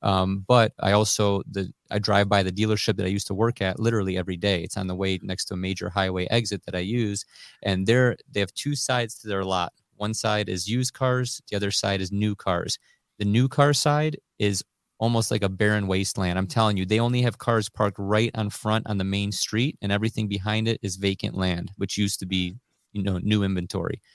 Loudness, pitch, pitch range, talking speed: -25 LUFS, 105 Hz, 95-110 Hz, 230 wpm